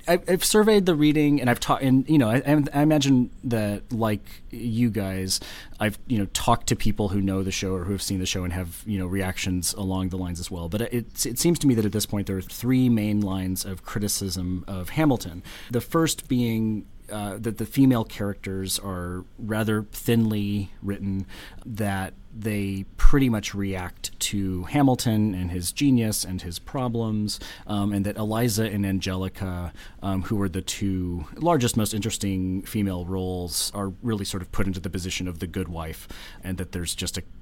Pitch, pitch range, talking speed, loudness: 100 Hz, 95-115 Hz, 190 wpm, -25 LUFS